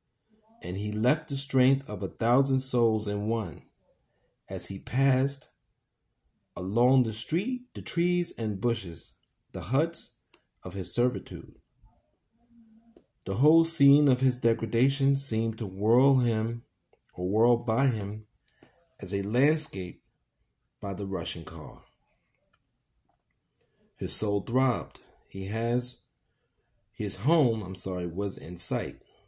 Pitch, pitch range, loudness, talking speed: 115 Hz, 100-135 Hz, -27 LUFS, 120 wpm